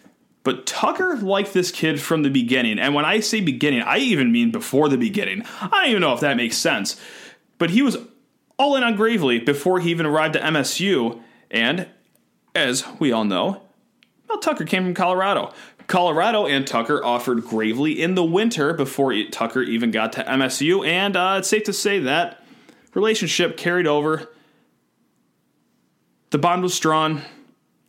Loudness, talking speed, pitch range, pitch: -20 LUFS, 170 wpm, 145-215 Hz, 175 Hz